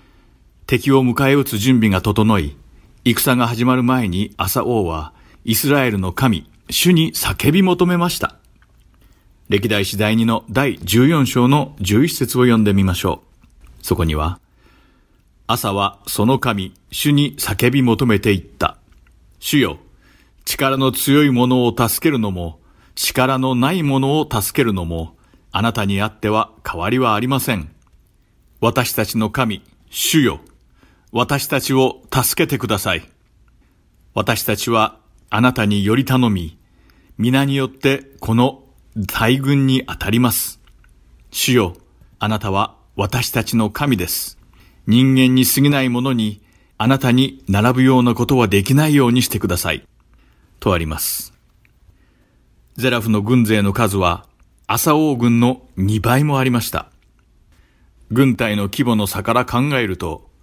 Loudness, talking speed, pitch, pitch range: -17 LUFS, 245 characters per minute, 115 Hz, 100-130 Hz